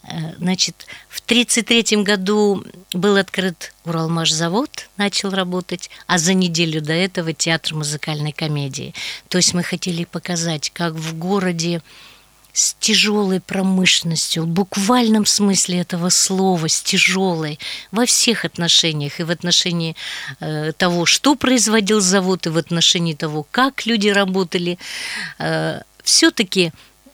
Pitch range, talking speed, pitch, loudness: 165-200 Hz, 115 wpm, 180 Hz, -17 LUFS